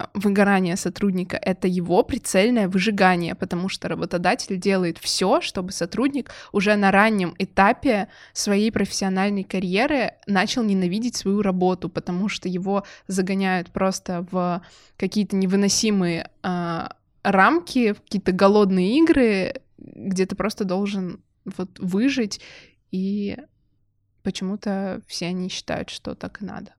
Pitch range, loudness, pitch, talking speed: 185-205 Hz, -22 LUFS, 195 Hz, 115 wpm